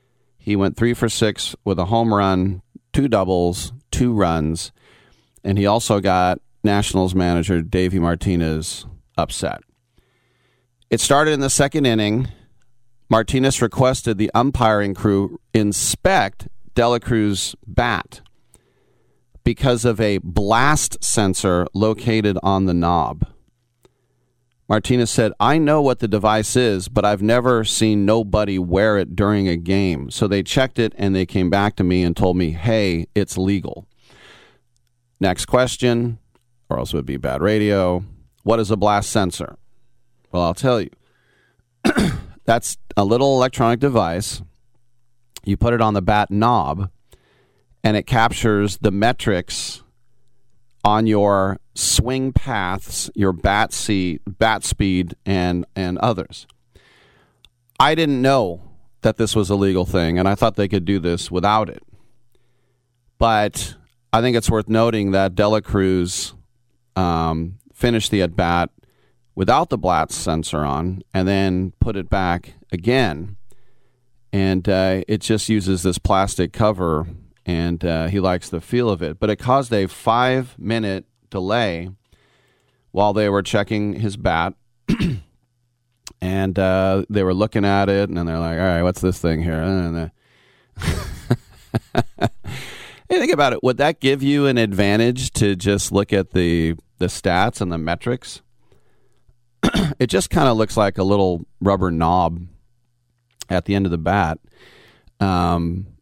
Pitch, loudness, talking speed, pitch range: 105 Hz, -19 LUFS, 145 wpm, 95-120 Hz